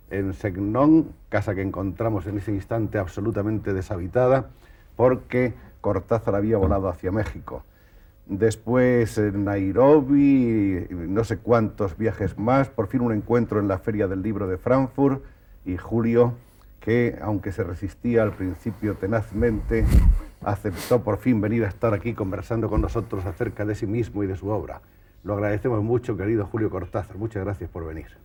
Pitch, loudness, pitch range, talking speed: 105 Hz, -24 LUFS, 100-115 Hz, 155 wpm